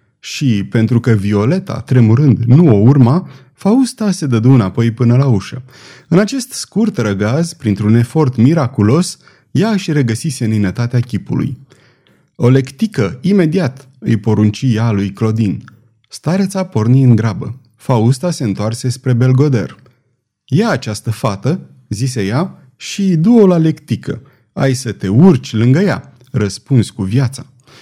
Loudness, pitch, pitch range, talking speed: -13 LUFS, 130 Hz, 115-150 Hz, 135 wpm